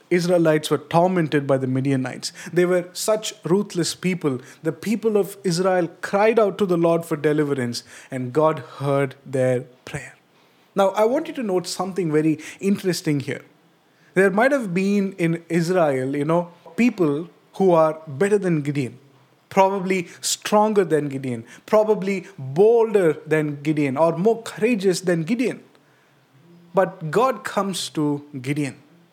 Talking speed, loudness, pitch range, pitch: 140 wpm, -21 LUFS, 150-195 Hz, 170 Hz